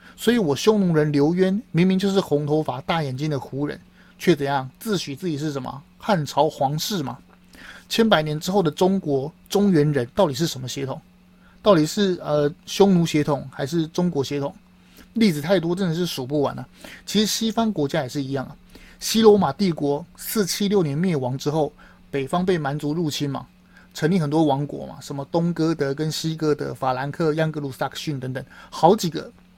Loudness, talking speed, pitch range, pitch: -22 LUFS, 285 characters per minute, 145-190 Hz, 155 Hz